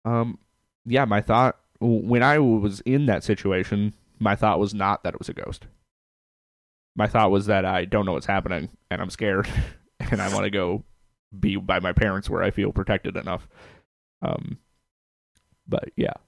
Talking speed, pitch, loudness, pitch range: 175 wpm, 105 Hz, -24 LUFS, 95-115 Hz